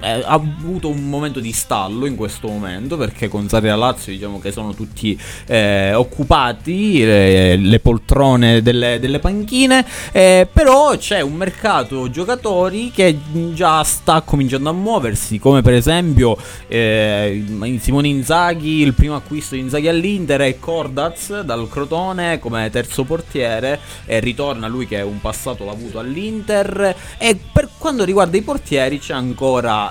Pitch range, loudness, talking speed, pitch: 110-170 Hz, -16 LUFS, 155 wpm, 135 Hz